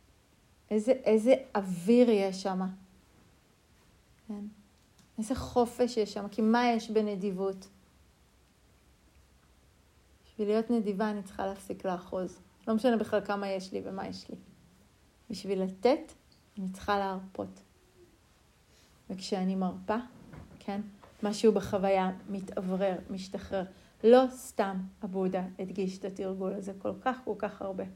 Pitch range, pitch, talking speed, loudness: 185-215 Hz, 195 Hz, 115 wpm, -31 LUFS